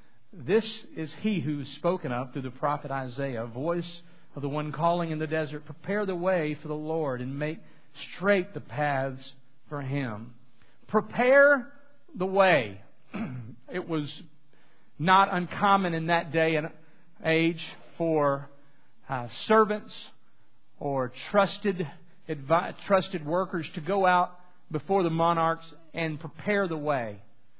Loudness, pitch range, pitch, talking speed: -28 LUFS, 140-180 Hz, 160 Hz, 135 wpm